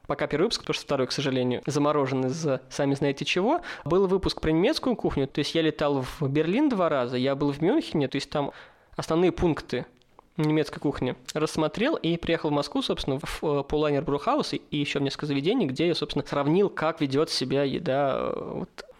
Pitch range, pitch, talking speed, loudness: 140-165 Hz, 150 Hz, 185 wpm, -26 LUFS